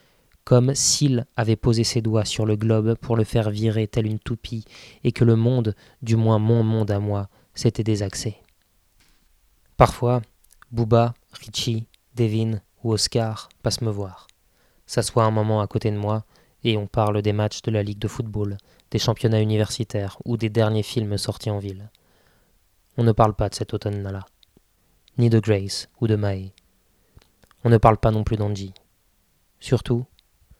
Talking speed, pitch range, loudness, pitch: 165 wpm, 100-115 Hz, -22 LUFS, 110 Hz